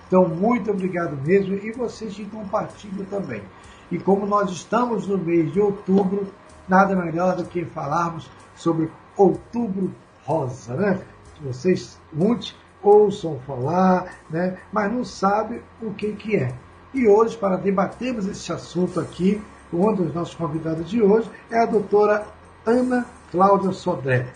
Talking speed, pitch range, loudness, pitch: 140 wpm, 170-210 Hz, -22 LUFS, 195 Hz